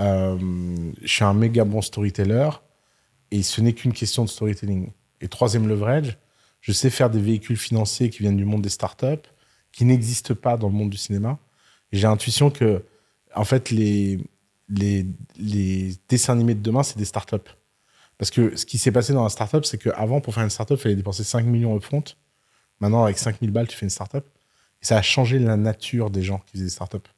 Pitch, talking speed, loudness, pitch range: 110 Hz, 210 wpm, -22 LUFS, 100-120 Hz